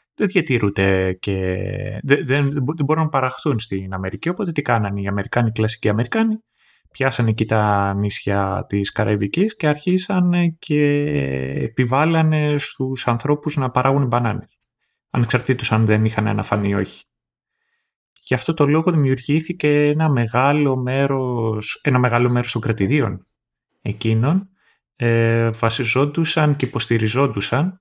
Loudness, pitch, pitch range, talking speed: -19 LUFS, 130 Hz, 110-150 Hz, 125 wpm